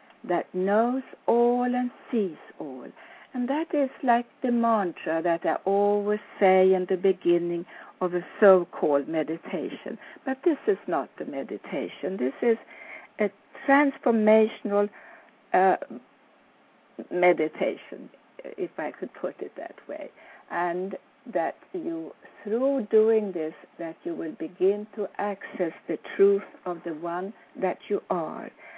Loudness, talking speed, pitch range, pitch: -26 LUFS, 130 wpm, 180-250 Hz, 205 Hz